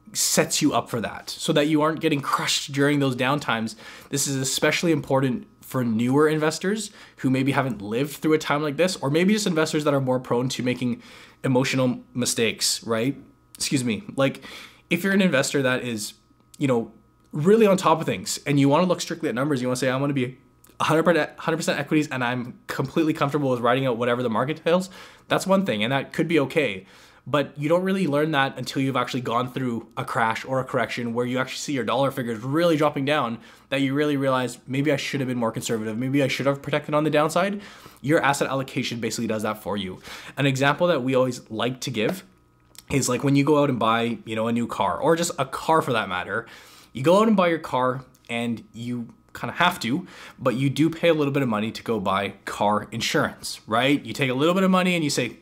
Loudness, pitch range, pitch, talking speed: -23 LUFS, 125-155 Hz, 135 Hz, 235 wpm